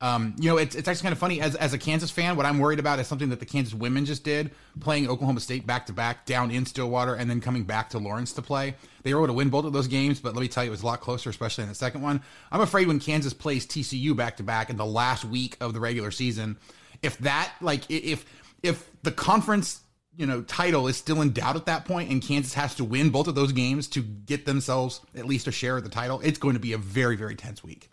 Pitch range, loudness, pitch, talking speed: 125-150 Hz, -27 LUFS, 135 Hz, 275 wpm